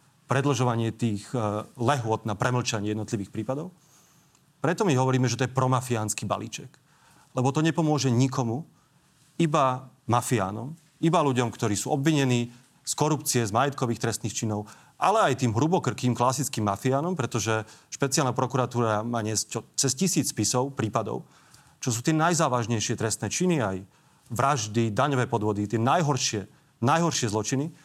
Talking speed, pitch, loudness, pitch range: 130 wpm, 130 Hz, -26 LUFS, 115-145 Hz